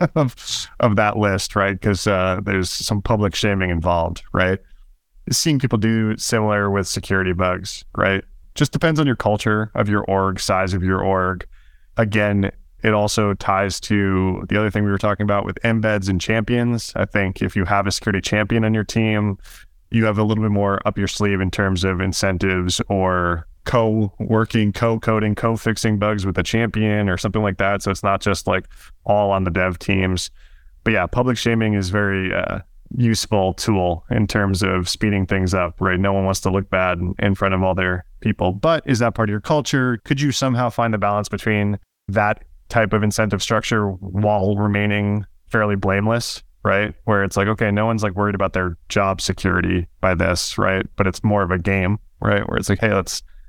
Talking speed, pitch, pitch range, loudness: 200 wpm, 100 Hz, 95-110 Hz, -20 LUFS